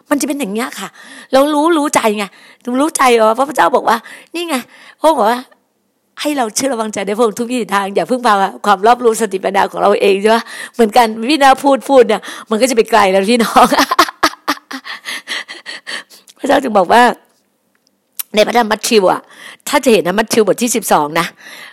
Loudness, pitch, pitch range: -13 LUFS, 240 Hz, 220-275 Hz